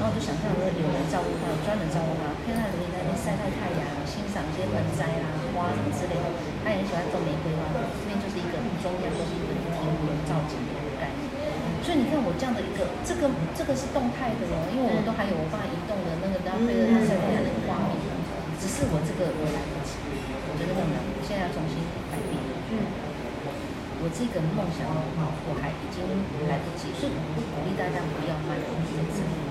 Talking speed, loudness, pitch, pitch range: 335 characters per minute, -29 LUFS, 180 Hz, 160-200 Hz